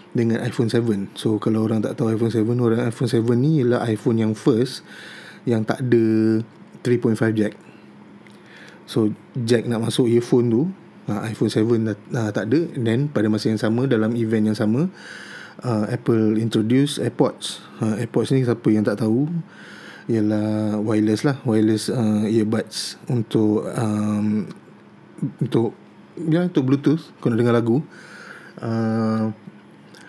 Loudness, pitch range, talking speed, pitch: -21 LUFS, 110-120 Hz, 145 wpm, 115 Hz